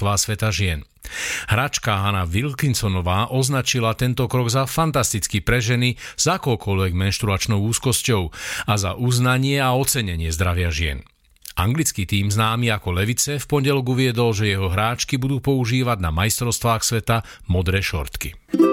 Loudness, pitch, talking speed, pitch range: -20 LUFS, 115 Hz, 130 wpm, 95-125 Hz